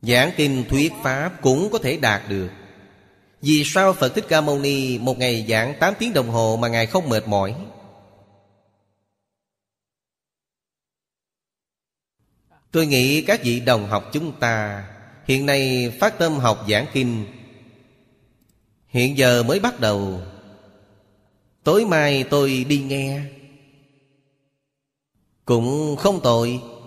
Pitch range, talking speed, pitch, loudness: 105-140 Hz, 125 wpm, 125 Hz, -20 LUFS